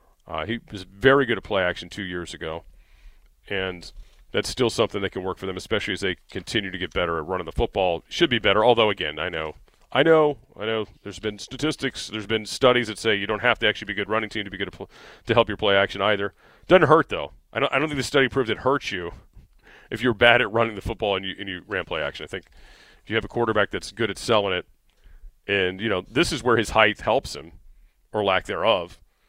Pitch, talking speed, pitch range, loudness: 105 Hz, 255 wpm, 95-120 Hz, -23 LUFS